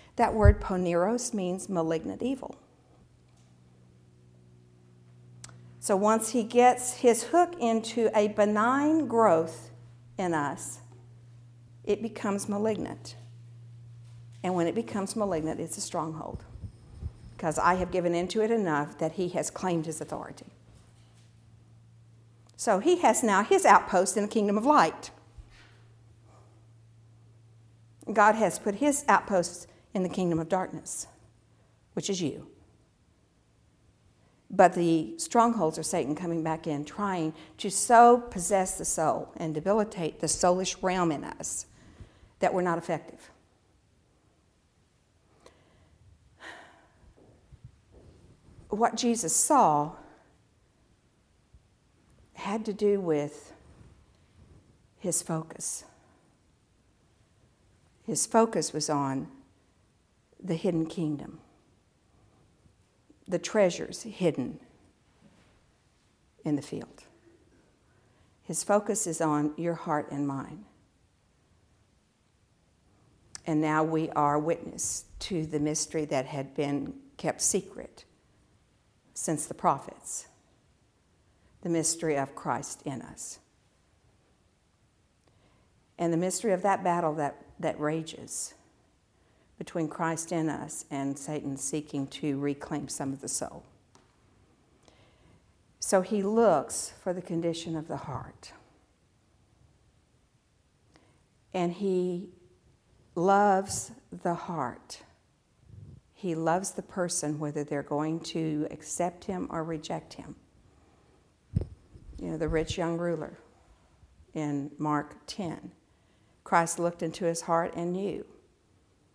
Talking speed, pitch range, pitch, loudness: 105 wpm, 120-185 Hz, 160 Hz, -29 LUFS